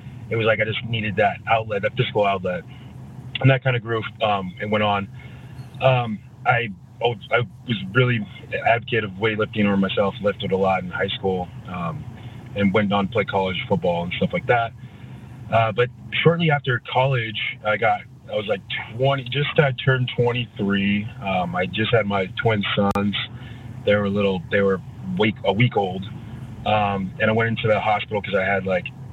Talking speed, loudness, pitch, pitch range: 185 wpm, -22 LUFS, 115 Hz, 100-125 Hz